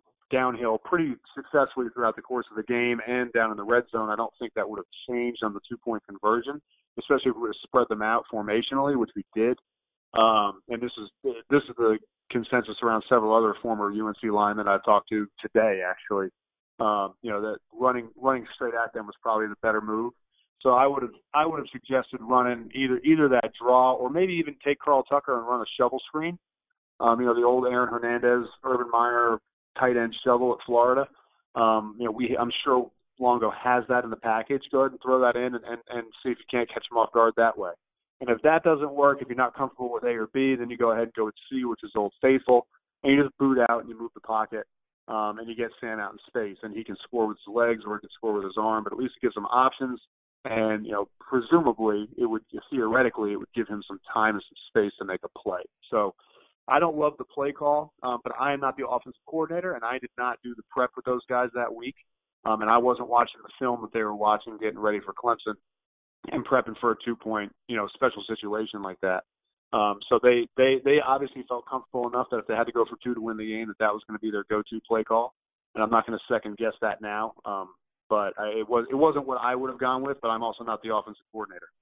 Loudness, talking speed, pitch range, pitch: -26 LUFS, 250 wpm, 110-130 Hz, 120 Hz